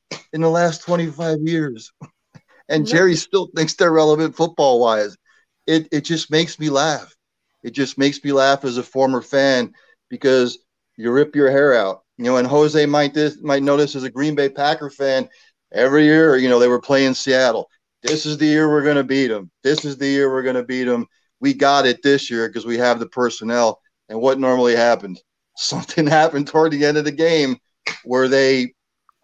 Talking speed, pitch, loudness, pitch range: 200 wpm, 140 Hz, -17 LUFS, 125-155 Hz